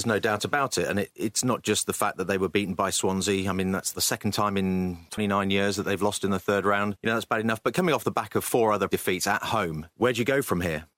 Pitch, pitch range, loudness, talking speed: 100 Hz, 95-105 Hz, -26 LUFS, 305 wpm